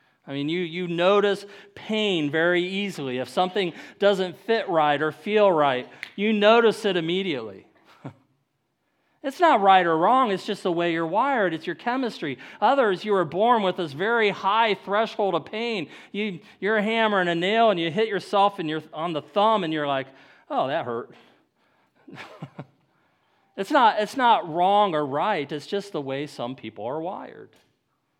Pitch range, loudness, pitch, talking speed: 160-210 Hz, -23 LUFS, 190 Hz, 175 wpm